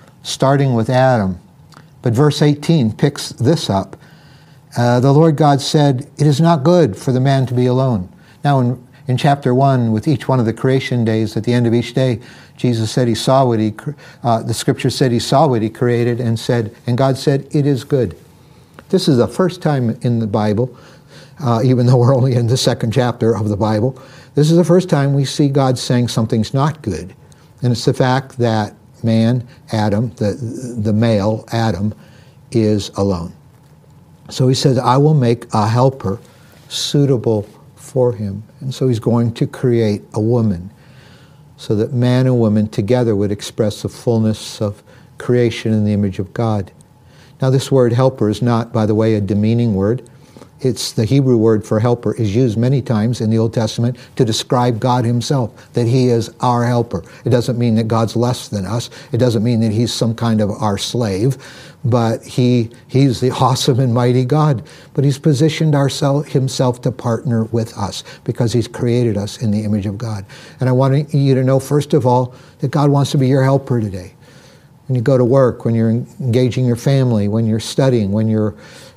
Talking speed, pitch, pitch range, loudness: 195 wpm, 125 Hz, 115-135 Hz, -16 LUFS